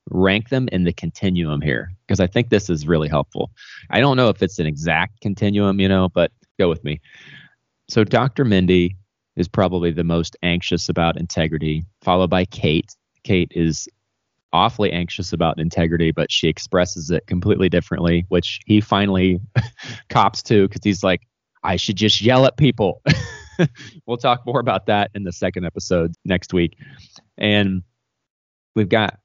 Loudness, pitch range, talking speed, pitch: -19 LUFS, 85-105 Hz, 165 wpm, 95 Hz